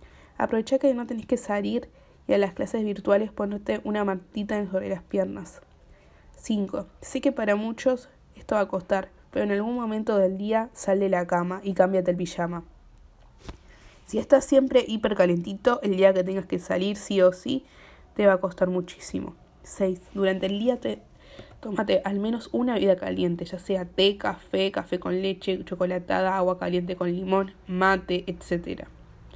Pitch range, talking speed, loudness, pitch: 185-215 Hz, 170 wpm, -26 LUFS, 195 Hz